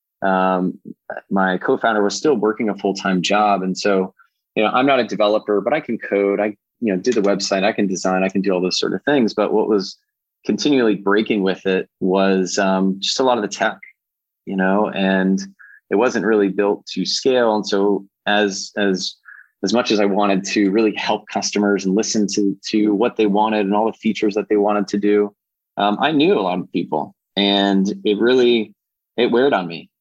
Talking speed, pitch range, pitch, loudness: 210 wpm, 95-105 Hz, 100 Hz, -18 LUFS